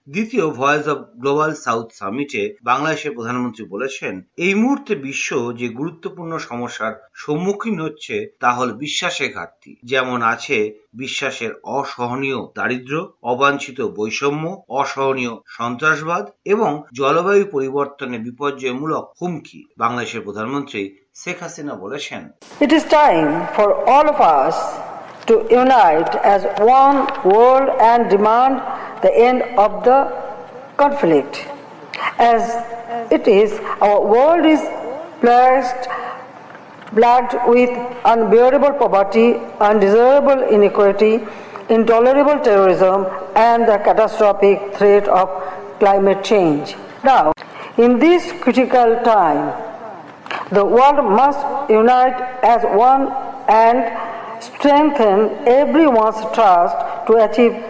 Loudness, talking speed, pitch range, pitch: -15 LUFS, 85 wpm, 150-250 Hz, 210 Hz